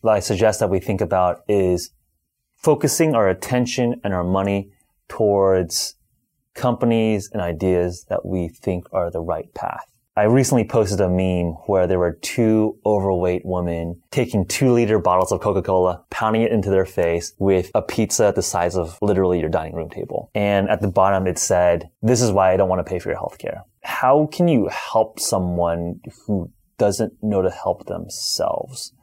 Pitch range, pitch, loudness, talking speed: 90-110 Hz, 95 Hz, -20 LUFS, 180 wpm